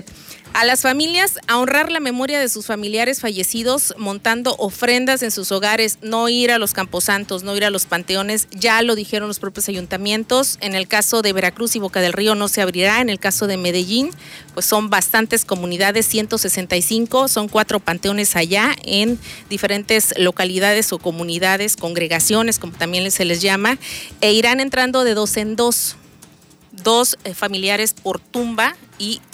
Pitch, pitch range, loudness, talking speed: 210 Hz, 190-230 Hz, -17 LUFS, 165 wpm